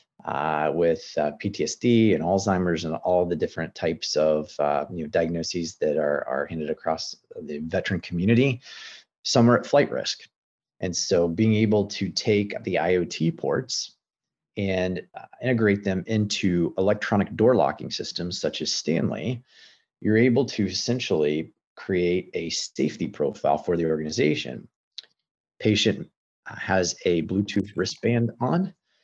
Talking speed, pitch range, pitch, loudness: 135 wpm, 85-110 Hz, 95 Hz, -25 LUFS